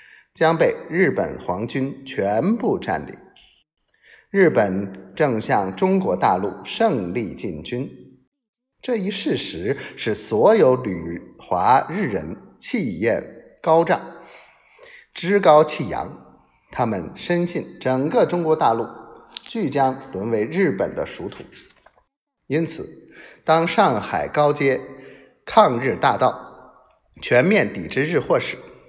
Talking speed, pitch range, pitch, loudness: 160 characters per minute, 135-205 Hz, 160 Hz, -20 LUFS